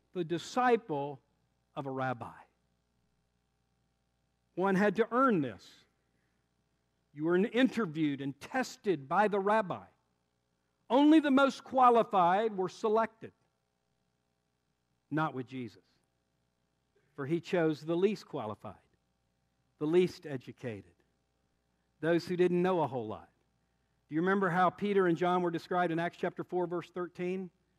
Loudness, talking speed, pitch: -31 LUFS, 125 wpm, 150 Hz